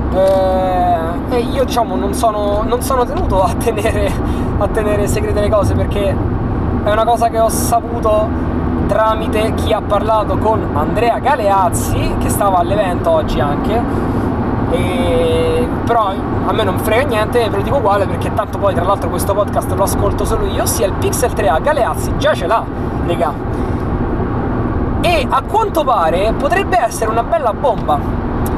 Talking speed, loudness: 155 wpm, -15 LUFS